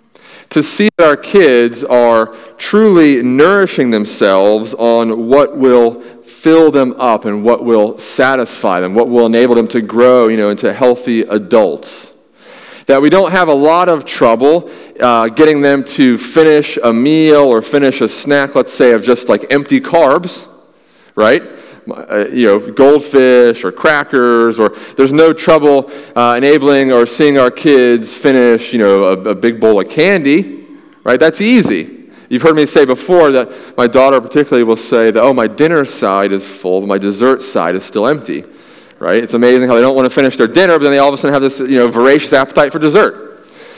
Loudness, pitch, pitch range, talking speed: -10 LUFS, 125 Hz, 115-145 Hz, 185 wpm